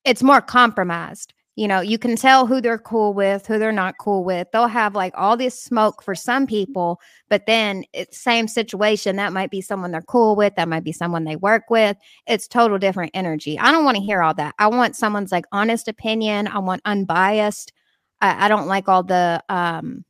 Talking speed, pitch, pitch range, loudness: 215 wpm, 205 Hz, 185-225 Hz, -19 LUFS